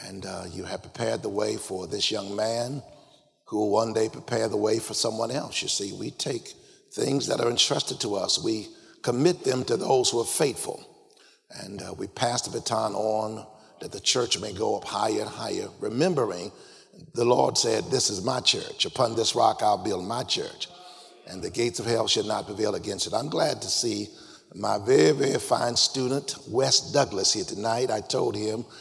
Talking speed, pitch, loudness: 200 wpm, 120 Hz, -26 LUFS